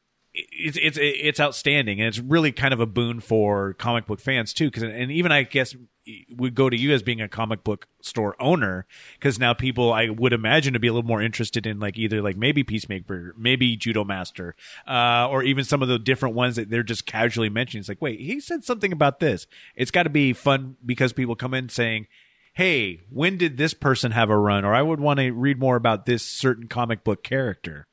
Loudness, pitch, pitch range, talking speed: -23 LUFS, 120 Hz, 110-140 Hz, 225 wpm